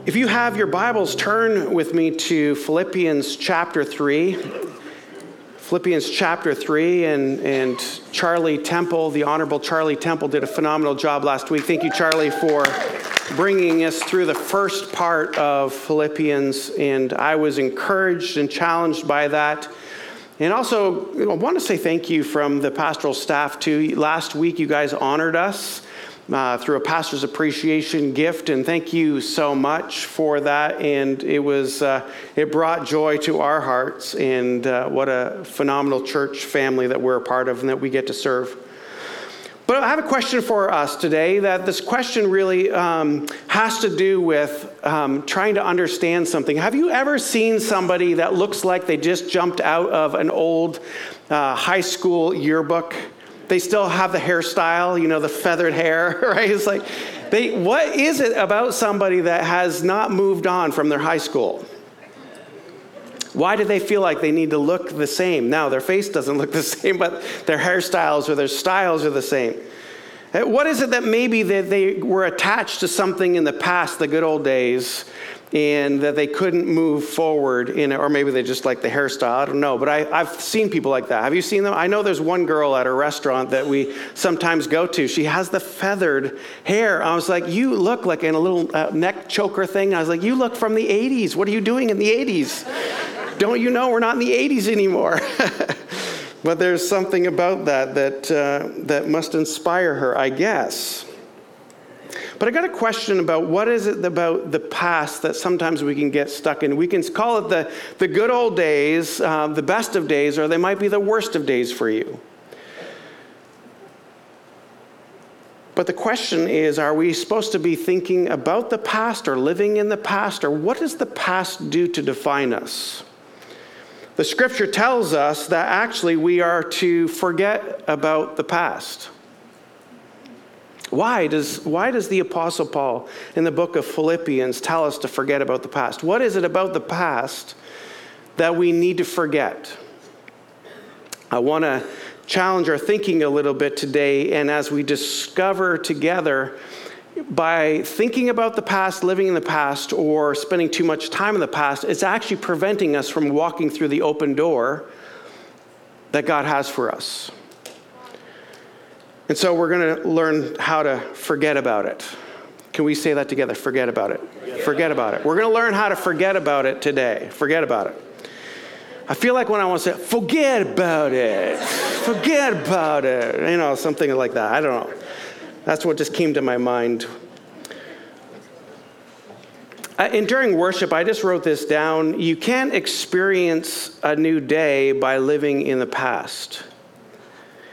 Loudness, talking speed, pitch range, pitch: -20 LUFS, 180 wpm, 150-195 Hz, 165 Hz